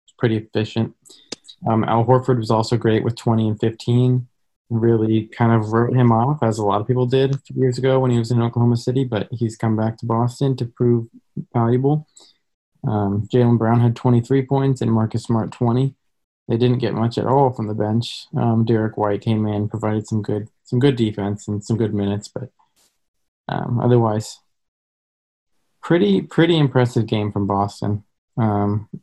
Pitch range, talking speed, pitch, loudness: 110-125 Hz, 185 wpm, 115 Hz, -19 LUFS